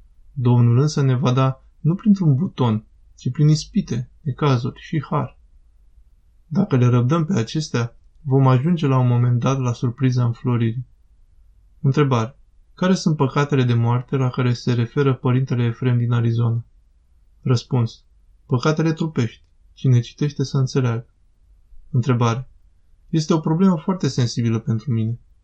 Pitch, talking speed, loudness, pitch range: 125 Hz, 135 wpm, -20 LUFS, 115-140 Hz